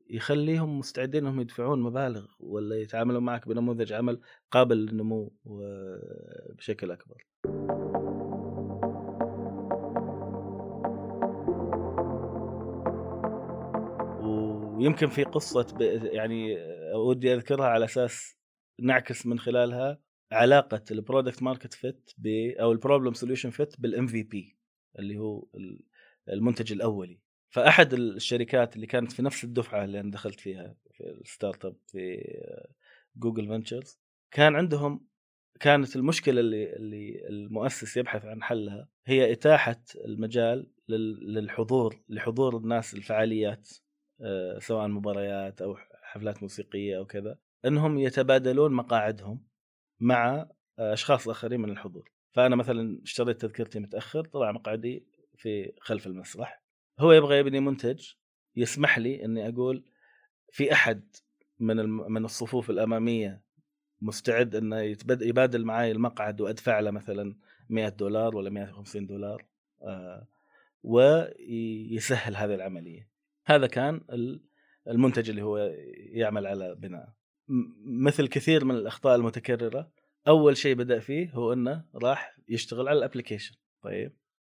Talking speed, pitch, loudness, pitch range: 110 wpm, 115 Hz, -28 LUFS, 110-130 Hz